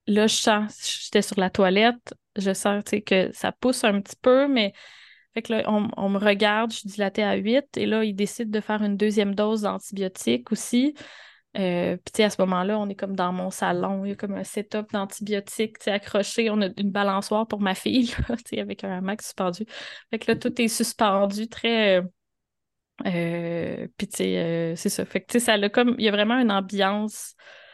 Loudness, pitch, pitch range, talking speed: -24 LUFS, 210 Hz, 195-220 Hz, 200 wpm